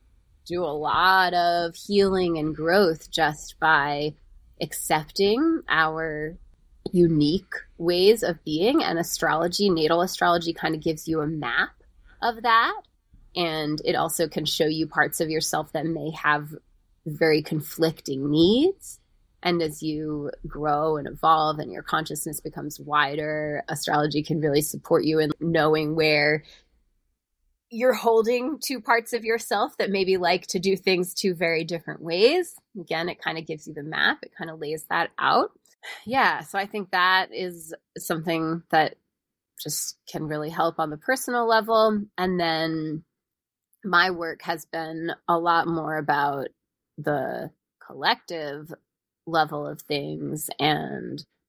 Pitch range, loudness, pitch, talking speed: 155-180 Hz, -24 LUFS, 160 Hz, 145 wpm